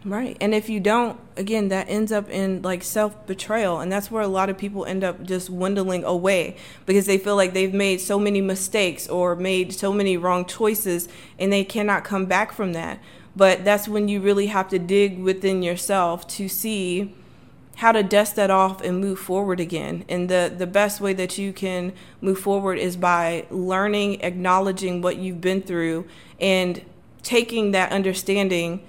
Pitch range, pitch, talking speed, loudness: 185-200 Hz, 190 Hz, 185 wpm, -22 LUFS